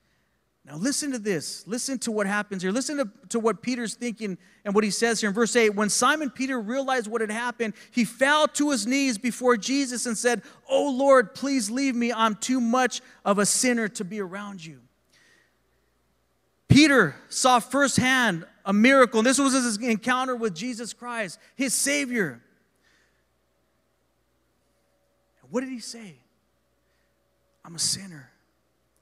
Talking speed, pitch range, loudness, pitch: 160 wpm, 200-255 Hz, -24 LUFS, 230 Hz